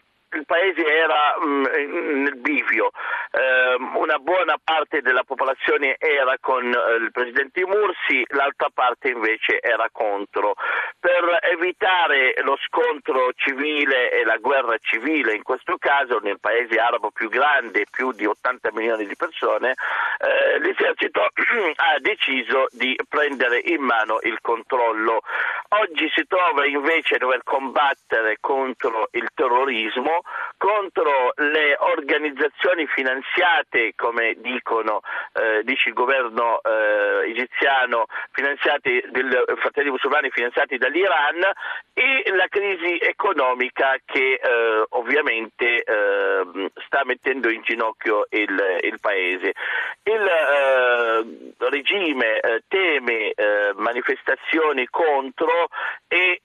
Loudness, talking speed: -20 LUFS, 115 wpm